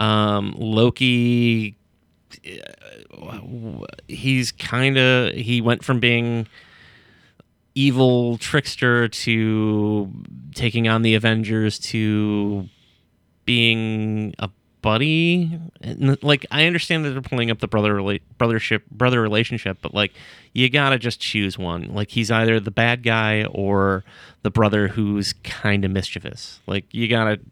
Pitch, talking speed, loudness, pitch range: 110 Hz, 125 wpm, -20 LUFS, 105-120 Hz